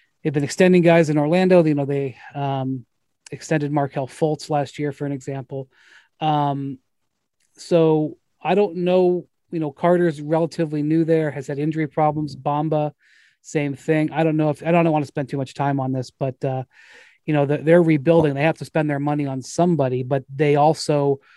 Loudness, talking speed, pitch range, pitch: -20 LUFS, 190 wpm, 140-160 Hz, 150 Hz